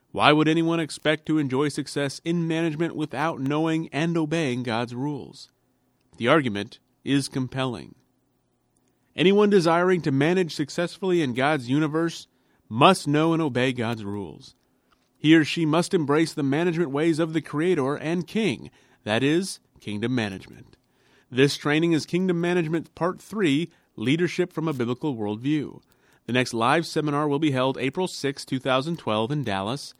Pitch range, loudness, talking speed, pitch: 130-165 Hz, -24 LUFS, 150 wpm, 150 Hz